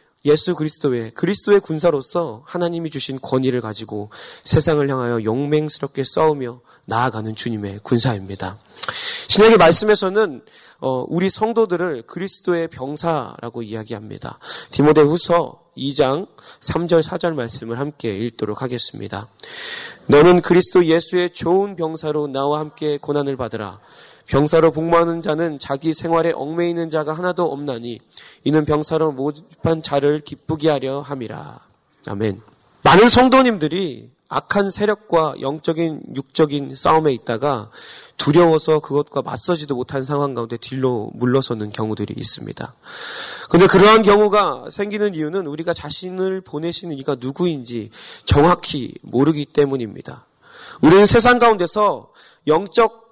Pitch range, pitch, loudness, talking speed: 130-175 Hz, 150 Hz, -18 LUFS, 320 characters per minute